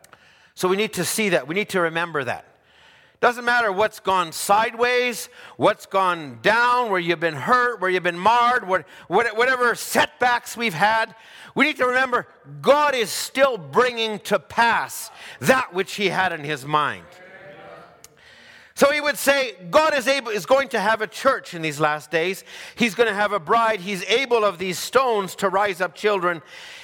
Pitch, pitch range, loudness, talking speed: 215 Hz, 185-245 Hz, -21 LUFS, 180 wpm